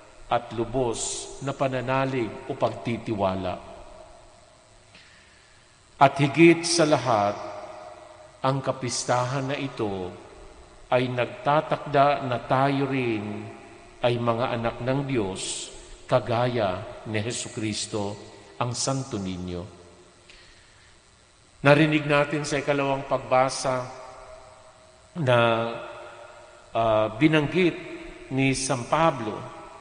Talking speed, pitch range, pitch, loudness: 85 wpm, 110-140 Hz, 125 Hz, -25 LUFS